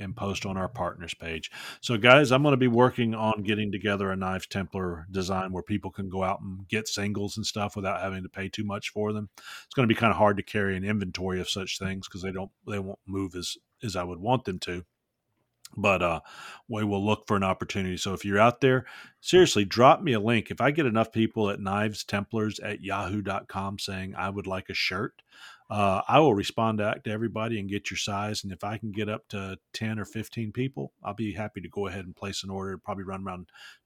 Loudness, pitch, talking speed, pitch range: -28 LUFS, 100 Hz, 235 wpm, 95-110 Hz